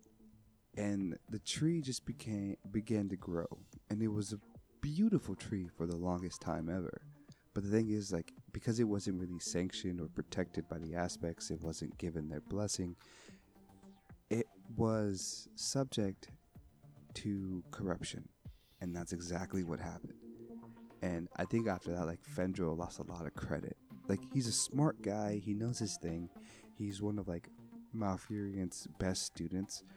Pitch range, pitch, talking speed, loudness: 90-110 Hz, 100 Hz, 155 wpm, -40 LUFS